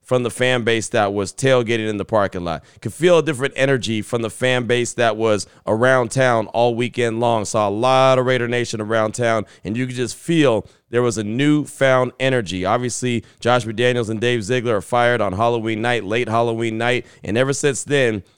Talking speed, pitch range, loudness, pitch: 205 wpm, 110-125 Hz, -19 LUFS, 120 Hz